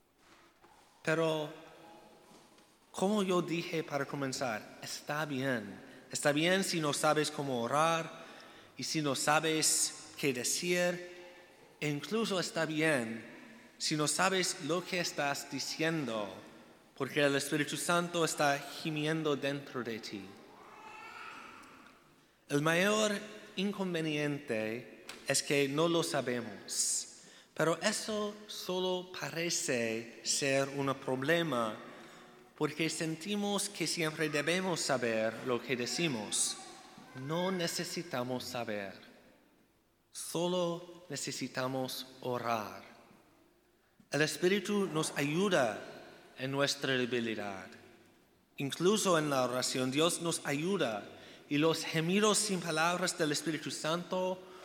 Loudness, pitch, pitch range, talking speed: -33 LUFS, 155 Hz, 130-175 Hz, 100 wpm